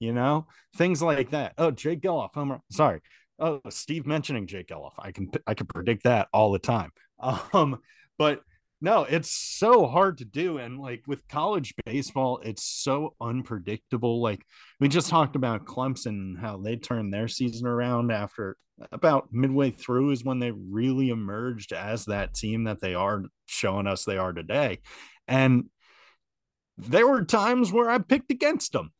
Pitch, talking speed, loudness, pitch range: 125 Hz, 165 wpm, -26 LUFS, 110-145 Hz